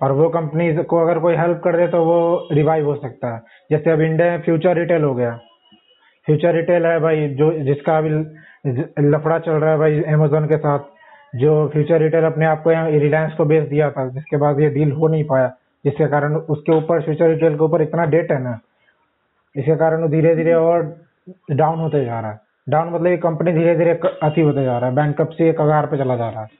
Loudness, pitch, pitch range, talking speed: -17 LUFS, 155 Hz, 150-165 Hz, 220 wpm